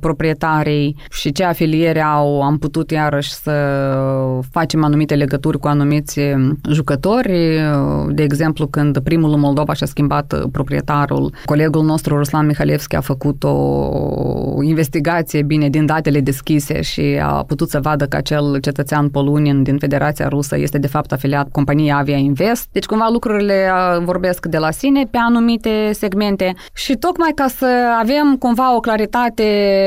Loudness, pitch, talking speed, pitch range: -16 LUFS, 150 Hz, 145 wpm, 145-185 Hz